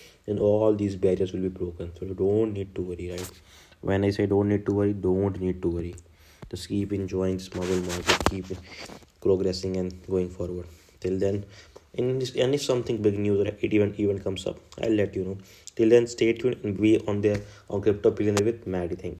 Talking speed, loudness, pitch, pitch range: 215 wpm, -26 LUFS, 95 Hz, 90-105 Hz